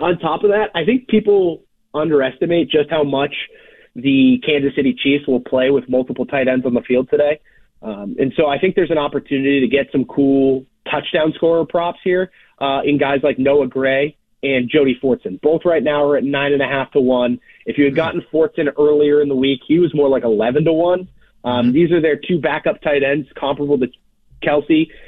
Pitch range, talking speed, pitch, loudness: 135-165 Hz, 205 wpm, 145 Hz, -16 LUFS